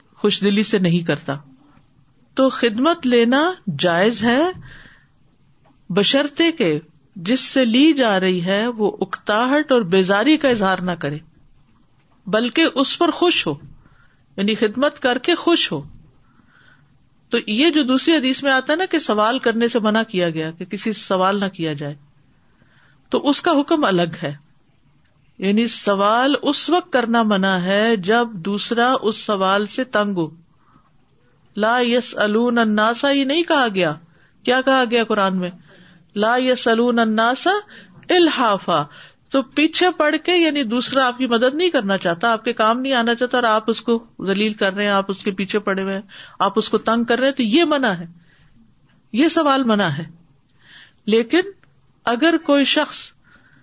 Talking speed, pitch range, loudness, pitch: 165 wpm, 185-265 Hz, -18 LUFS, 220 Hz